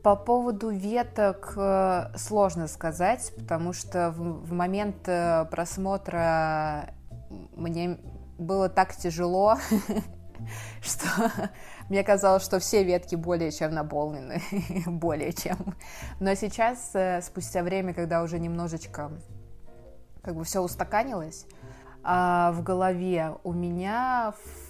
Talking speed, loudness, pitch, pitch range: 100 wpm, -28 LUFS, 175 Hz, 165-195 Hz